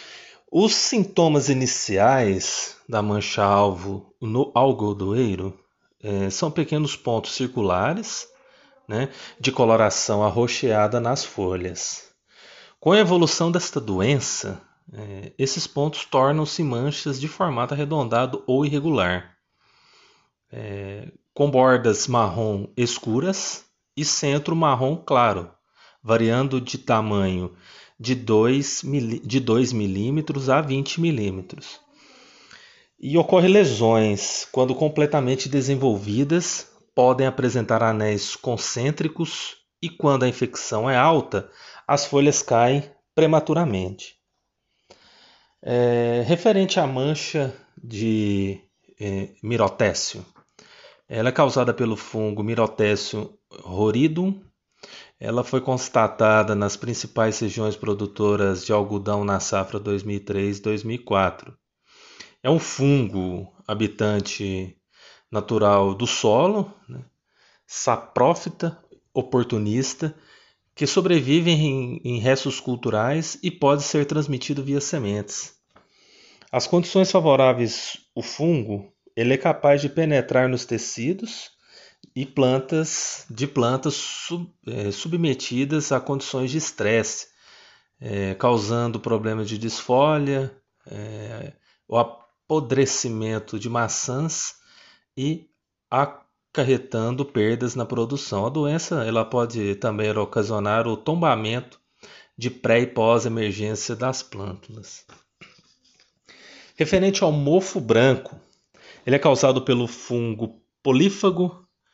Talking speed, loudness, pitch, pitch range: 100 wpm, -22 LUFS, 125 Hz, 110-145 Hz